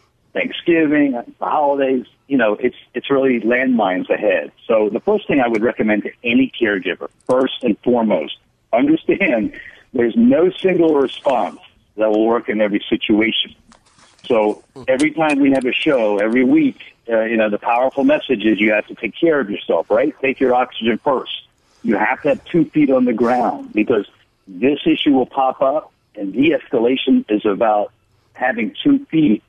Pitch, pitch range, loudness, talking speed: 130 Hz, 115-195 Hz, -17 LUFS, 170 wpm